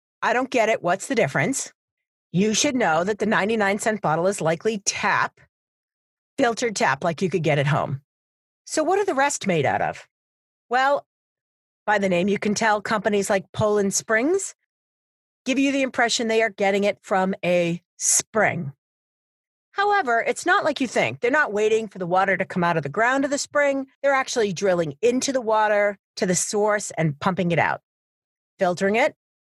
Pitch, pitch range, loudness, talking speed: 215 Hz, 185-255 Hz, -22 LUFS, 185 wpm